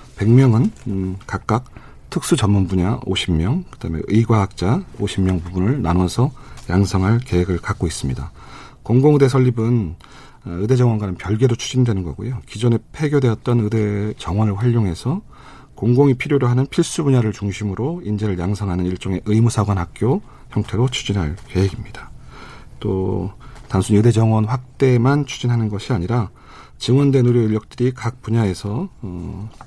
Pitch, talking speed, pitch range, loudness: 110 Hz, 315 characters per minute, 95-125 Hz, -19 LUFS